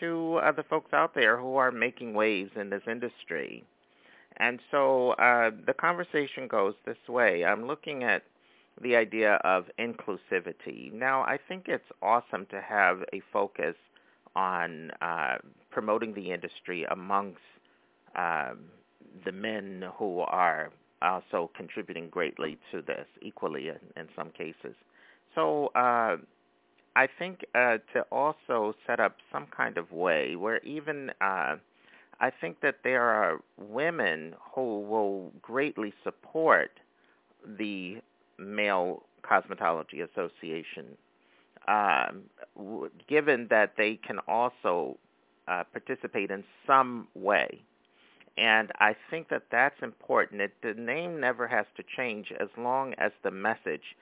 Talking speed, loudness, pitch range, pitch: 130 wpm, -29 LUFS, 95-130 Hz, 110 Hz